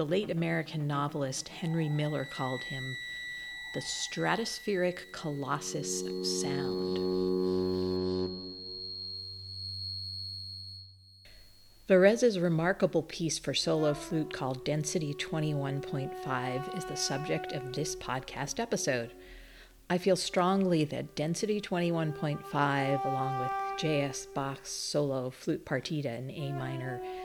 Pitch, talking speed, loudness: 140 Hz, 100 wpm, -32 LUFS